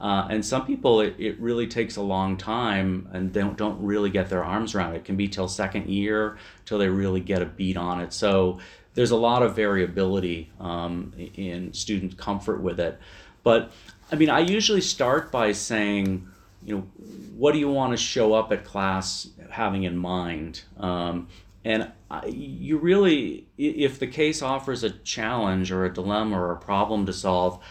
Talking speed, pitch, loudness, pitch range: 190 wpm, 100 Hz, -25 LUFS, 95-110 Hz